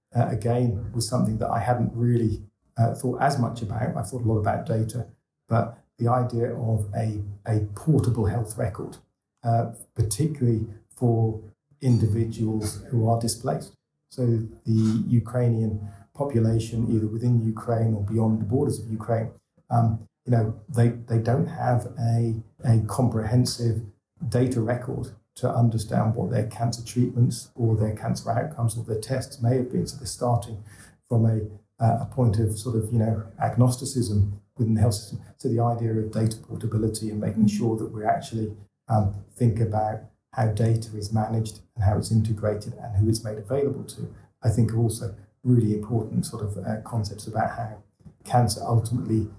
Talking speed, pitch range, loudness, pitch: 165 wpm, 110-120 Hz, -25 LUFS, 115 Hz